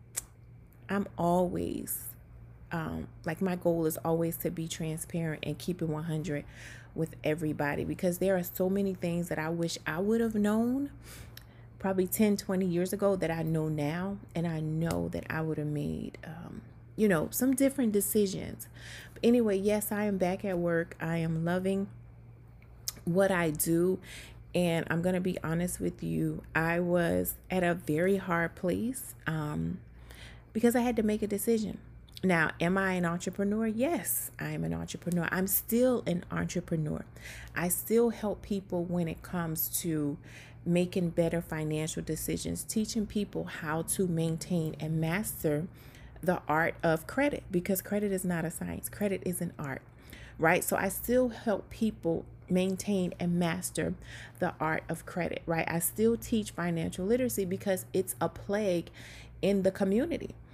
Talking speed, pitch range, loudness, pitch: 160 wpm, 155-195 Hz, -31 LUFS, 170 Hz